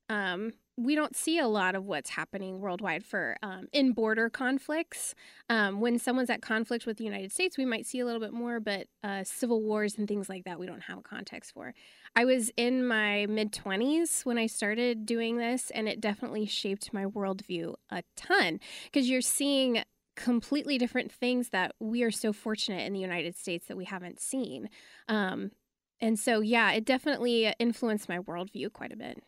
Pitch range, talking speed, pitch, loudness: 200-245 Hz, 195 wpm, 225 Hz, -31 LUFS